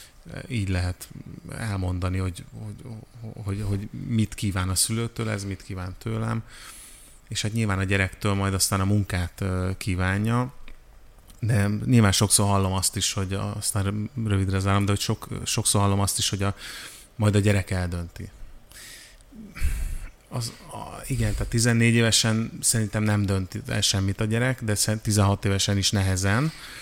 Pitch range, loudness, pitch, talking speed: 95-115 Hz, -24 LUFS, 105 Hz, 150 wpm